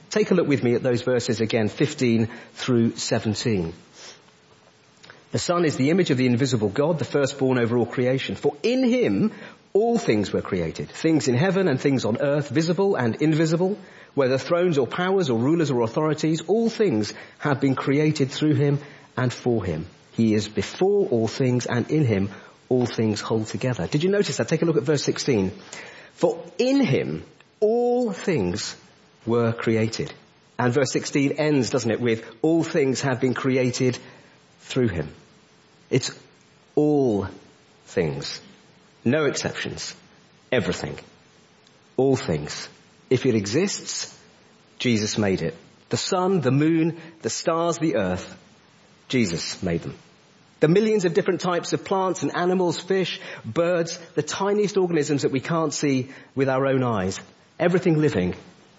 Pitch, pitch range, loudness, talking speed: 145 Hz, 120-170 Hz, -23 LUFS, 155 wpm